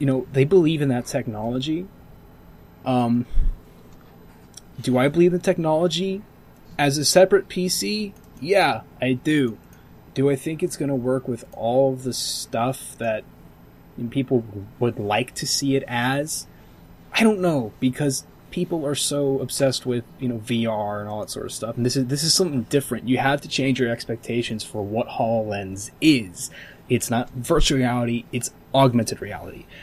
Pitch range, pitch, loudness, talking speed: 120-145 Hz, 130 Hz, -22 LUFS, 170 wpm